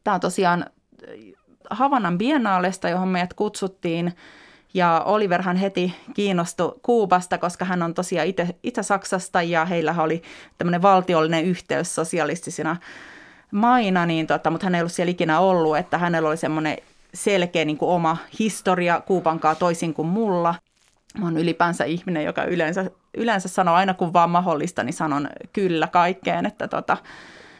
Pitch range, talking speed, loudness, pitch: 165-190 Hz, 145 wpm, -22 LUFS, 175 Hz